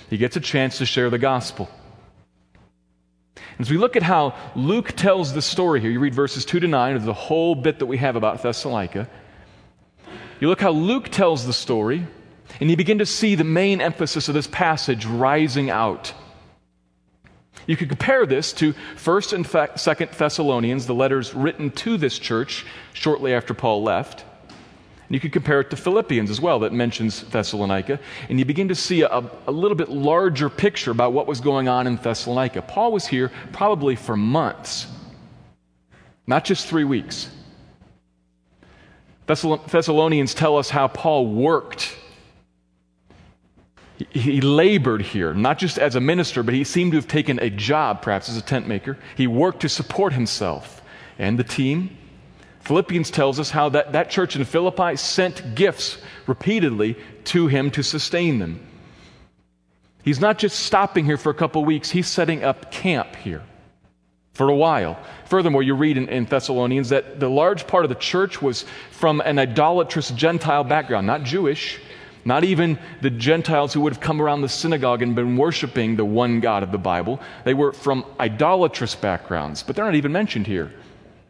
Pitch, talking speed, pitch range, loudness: 140 Hz, 175 wpm, 120-160 Hz, -21 LUFS